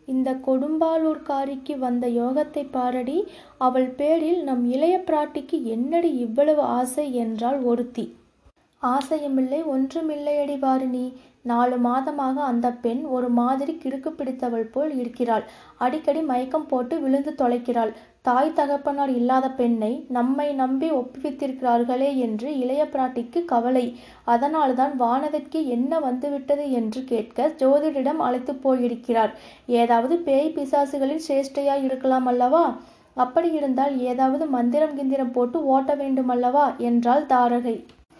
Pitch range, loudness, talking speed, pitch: 245-290 Hz, -23 LUFS, 110 wpm, 265 Hz